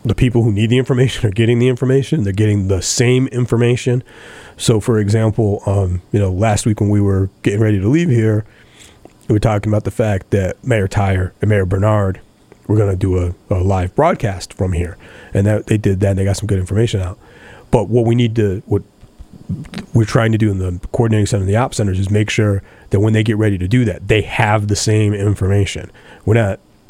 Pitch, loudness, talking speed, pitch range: 105 Hz, -16 LUFS, 225 wpm, 100-115 Hz